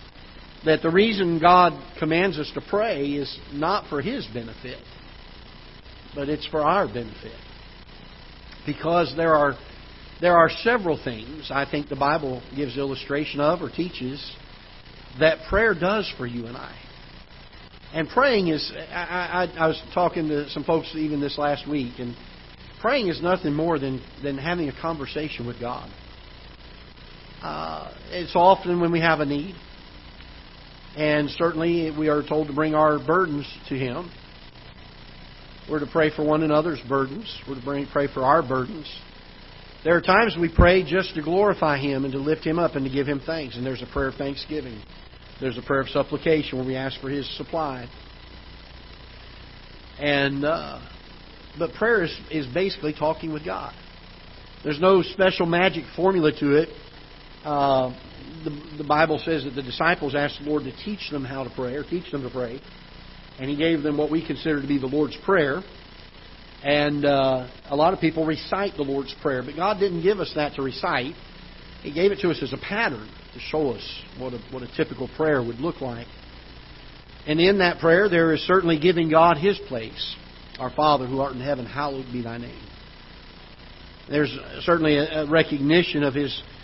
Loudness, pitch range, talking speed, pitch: -23 LUFS, 130-160 Hz, 175 wpm, 145 Hz